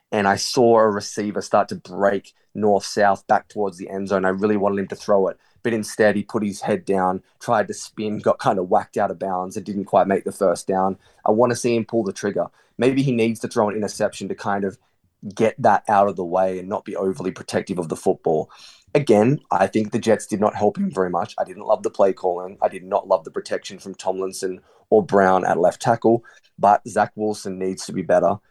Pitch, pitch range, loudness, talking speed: 100 Hz, 95-110 Hz, -21 LUFS, 240 wpm